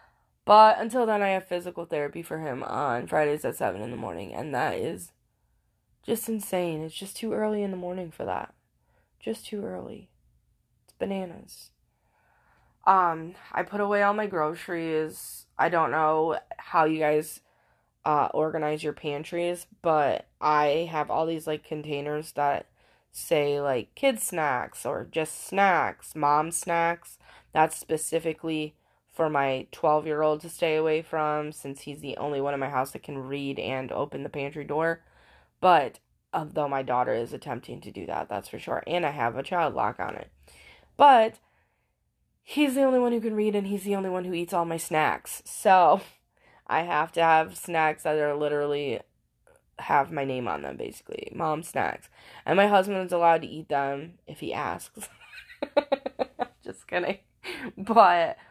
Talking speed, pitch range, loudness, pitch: 165 wpm, 150-185 Hz, -27 LUFS, 160 Hz